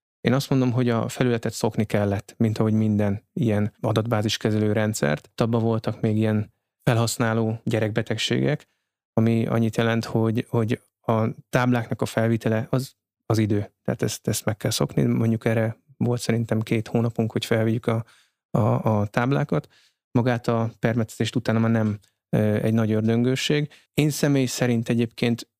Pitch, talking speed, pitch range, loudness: 115 Hz, 150 wpm, 110-120 Hz, -24 LUFS